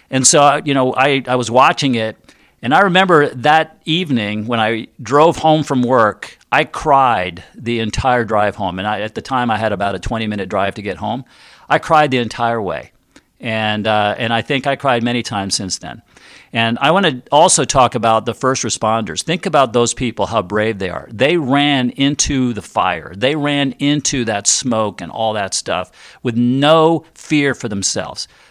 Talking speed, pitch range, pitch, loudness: 200 wpm, 110-140 Hz, 120 Hz, -15 LUFS